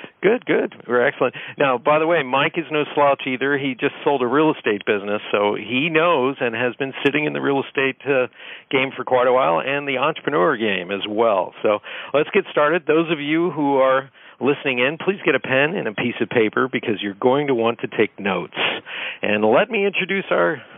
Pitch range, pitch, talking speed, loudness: 125-155 Hz, 135 Hz, 220 wpm, -20 LUFS